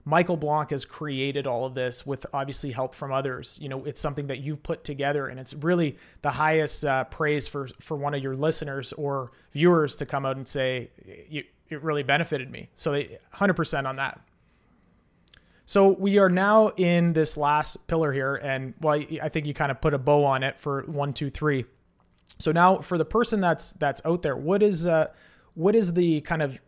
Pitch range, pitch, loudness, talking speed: 135-165 Hz, 150 Hz, -25 LUFS, 205 wpm